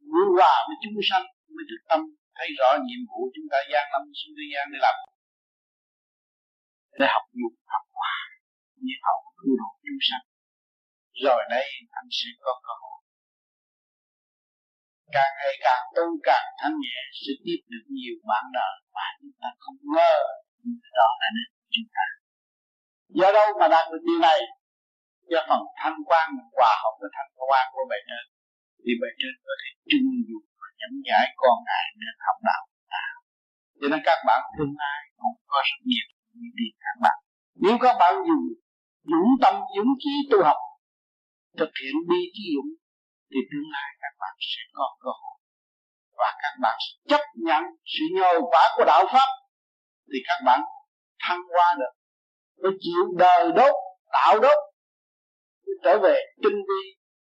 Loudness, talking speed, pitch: -23 LUFS, 170 wpm, 285 Hz